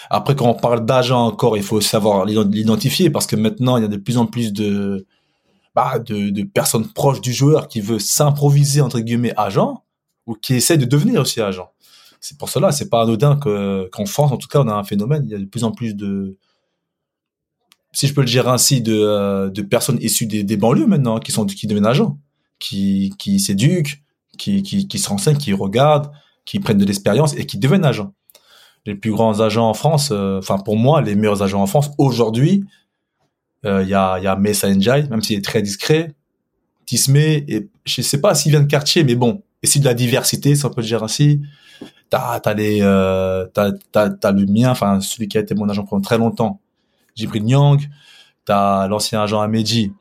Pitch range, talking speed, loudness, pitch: 105-145 Hz, 220 wpm, -17 LUFS, 115 Hz